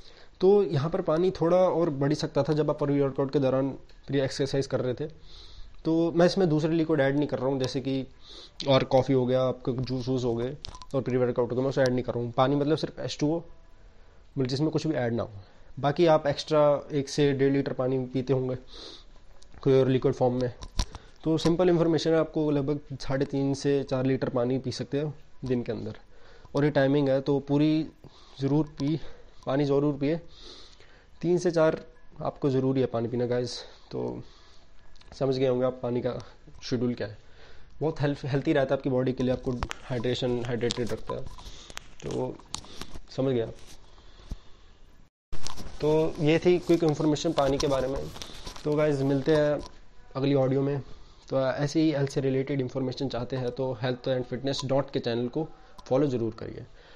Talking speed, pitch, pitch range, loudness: 190 wpm, 135 Hz, 125-150 Hz, -27 LUFS